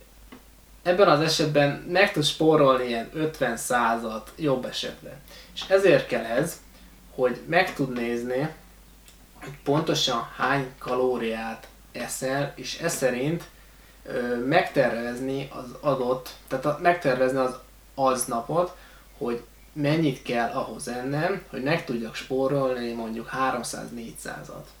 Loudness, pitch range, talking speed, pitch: -25 LUFS, 125-155 Hz, 115 wpm, 135 Hz